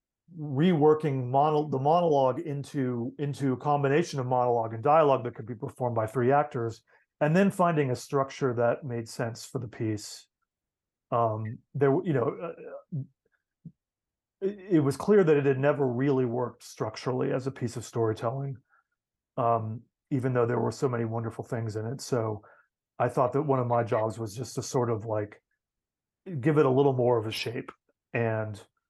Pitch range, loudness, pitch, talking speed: 115-145 Hz, -28 LUFS, 130 Hz, 175 wpm